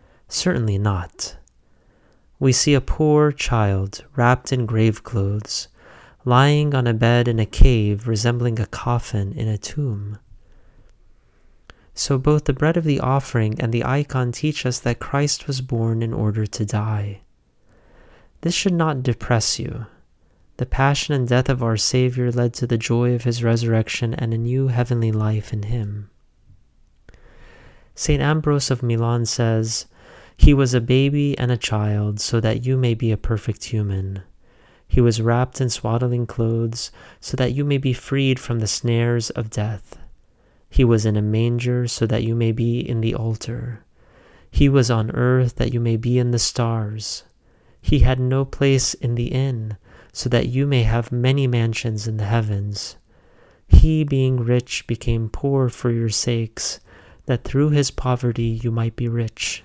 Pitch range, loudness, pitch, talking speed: 110-130 Hz, -20 LUFS, 120 Hz, 165 wpm